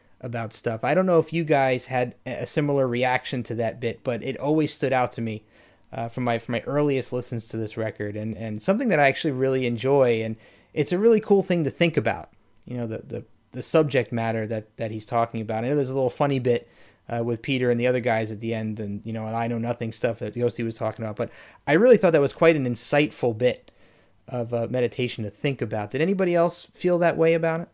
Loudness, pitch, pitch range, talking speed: -24 LUFS, 120 Hz, 115-145 Hz, 245 wpm